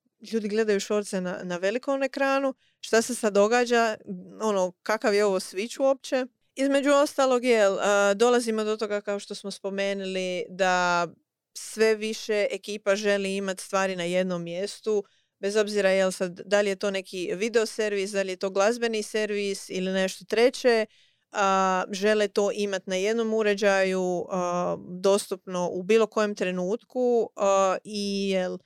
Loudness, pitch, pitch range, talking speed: -26 LUFS, 205 Hz, 190-220 Hz, 155 wpm